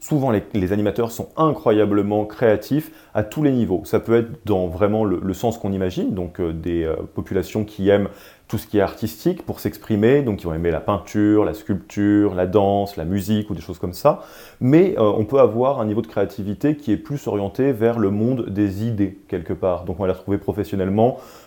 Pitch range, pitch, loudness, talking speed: 95-115 Hz, 105 Hz, -21 LUFS, 220 wpm